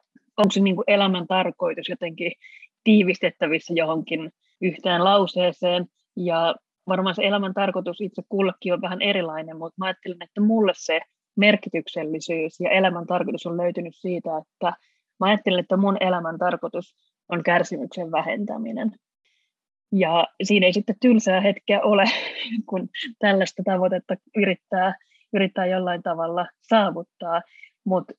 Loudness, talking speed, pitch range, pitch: -23 LUFS, 125 wpm, 175-200 Hz, 185 Hz